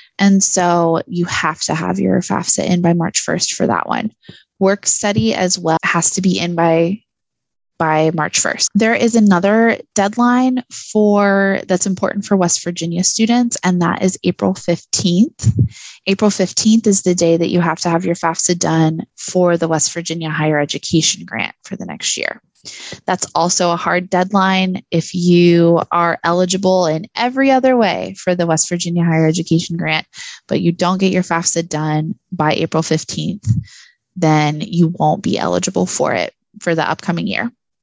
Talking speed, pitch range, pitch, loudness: 170 wpm, 165-195 Hz, 180 Hz, -15 LUFS